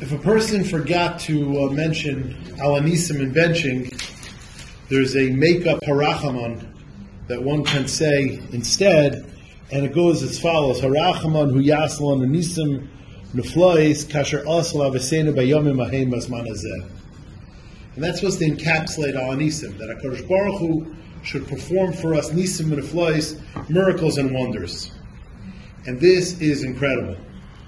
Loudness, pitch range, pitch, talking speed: -20 LUFS, 130-160 Hz, 145 Hz, 125 wpm